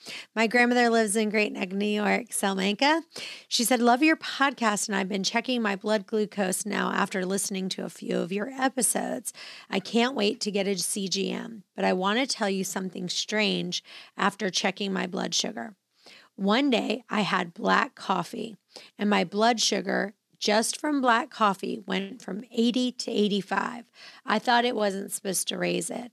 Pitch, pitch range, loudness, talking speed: 210 Hz, 195-235 Hz, -26 LUFS, 175 wpm